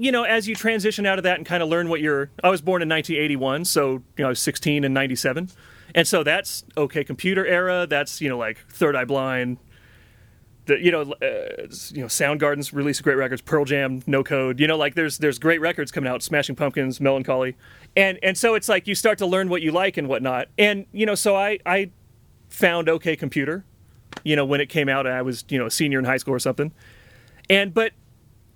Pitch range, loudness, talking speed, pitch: 135-180 Hz, -22 LUFS, 230 wpm, 150 Hz